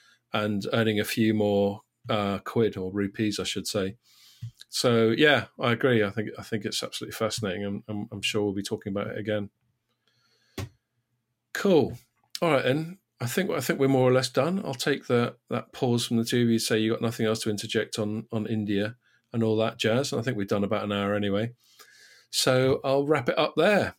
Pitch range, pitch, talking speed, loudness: 105-120 Hz, 110 Hz, 215 wpm, -26 LUFS